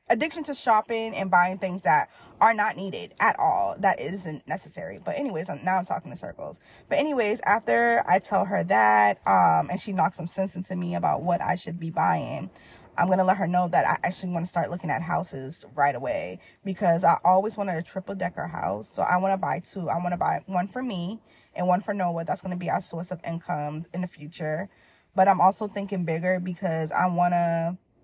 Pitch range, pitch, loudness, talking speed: 165-195 Hz, 180 Hz, -25 LUFS, 225 wpm